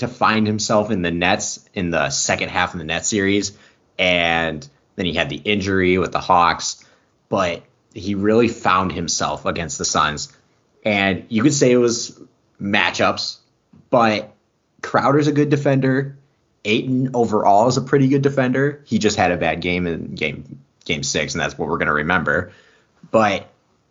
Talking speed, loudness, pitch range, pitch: 170 wpm, -19 LUFS, 90-130 Hz, 105 Hz